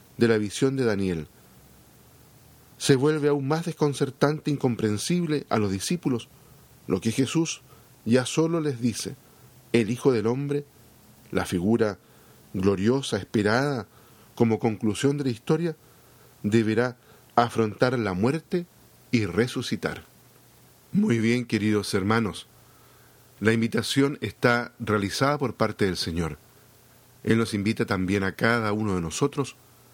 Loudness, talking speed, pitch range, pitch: -25 LUFS, 125 wpm, 105-135 Hz, 115 Hz